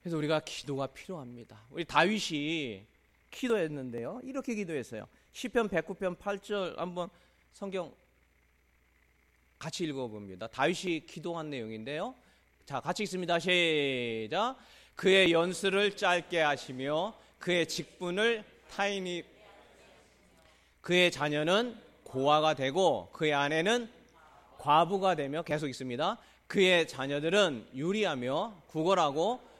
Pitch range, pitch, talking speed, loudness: 135-195 Hz, 165 Hz, 255 characters per minute, -31 LUFS